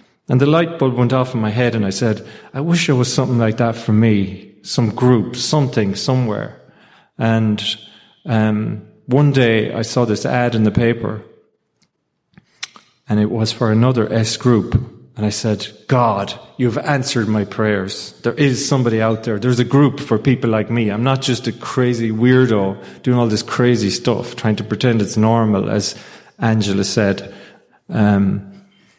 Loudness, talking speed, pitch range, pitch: -17 LUFS, 170 wpm, 110-125 Hz, 115 Hz